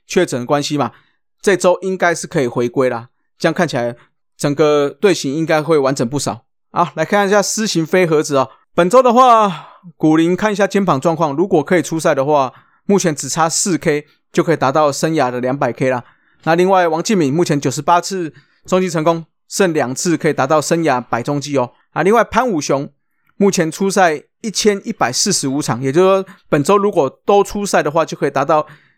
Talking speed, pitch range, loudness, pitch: 310 characters per minute, 145-185 Hz, -15 LUFS, 165 Hz